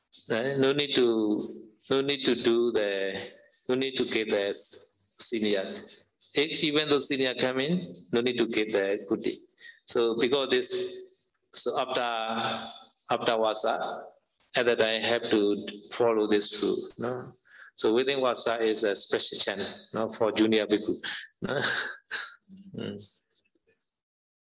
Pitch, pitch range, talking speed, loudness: 120 Hz, 110-155 Hz, 130 wpm, -27 LUFS